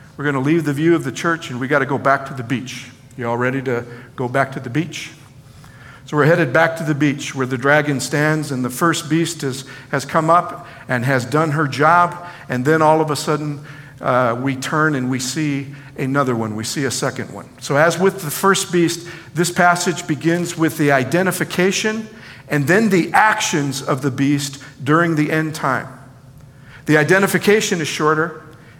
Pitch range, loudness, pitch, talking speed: 135-165 Hz, -18 LUFS, 150 Hz, 200 wpm